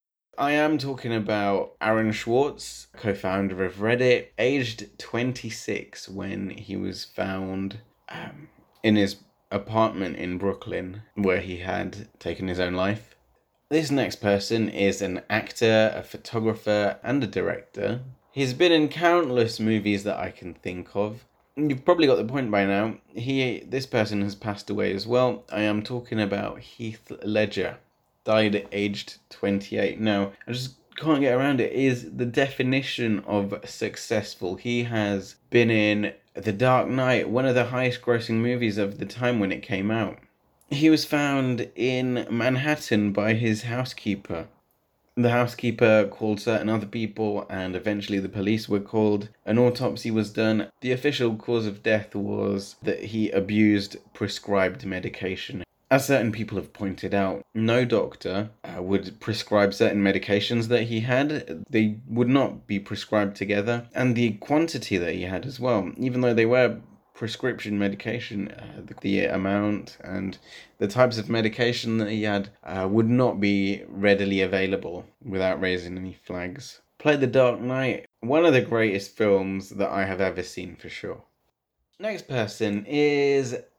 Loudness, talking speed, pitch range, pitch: -25 LUFS, 155 wpm, 100-125 Hz, 110 Hz